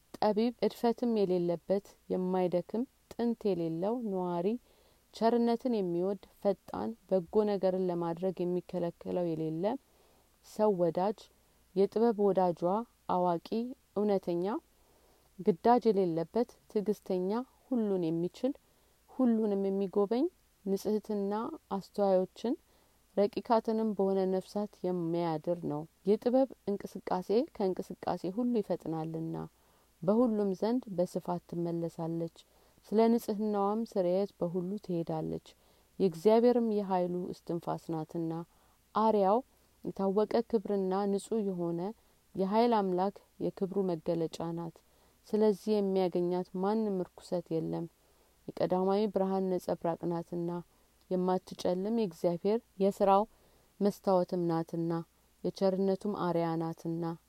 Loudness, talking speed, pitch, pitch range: -32 LUFS, 80 wpm, 195 Hz, 175-215 Hz